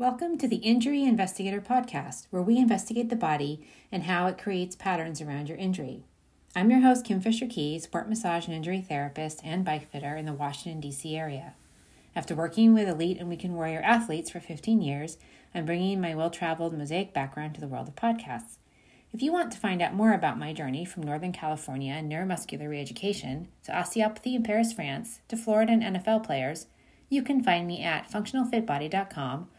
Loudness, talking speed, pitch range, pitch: -29 LUFS, 185 wpm, 155-220 Hz, 180 Hz